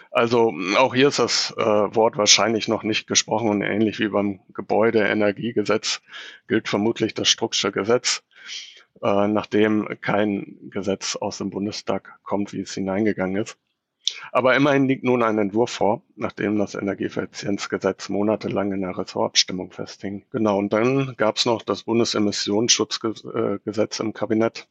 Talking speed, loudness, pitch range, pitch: 140 wpm, -22 LUFS, 100-110 Hz, 105 Hz